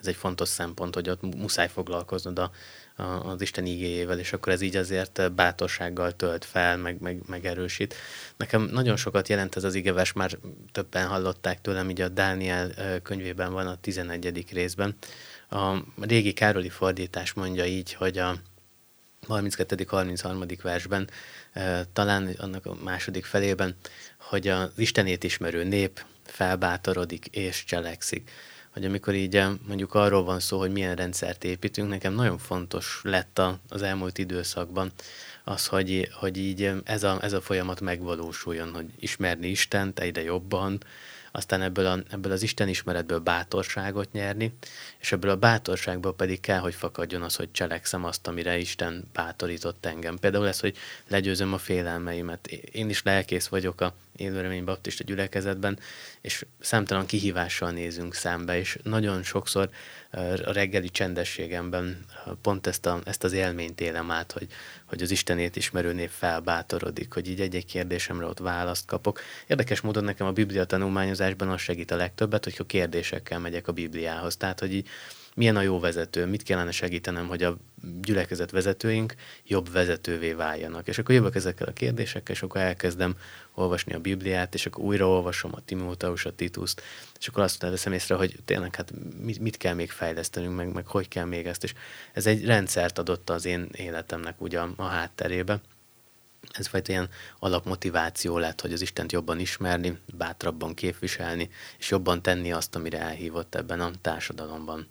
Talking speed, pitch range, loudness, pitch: 160 wpm, 90-100 Hz, -28 LUFS, 90 Hz